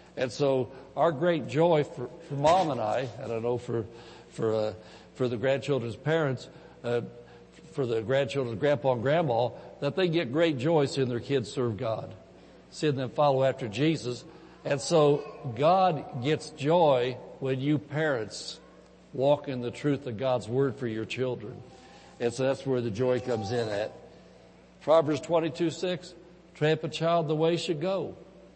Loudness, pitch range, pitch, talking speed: -28 LUFS, 120-160 Hz, 135 Hz, 165 wpm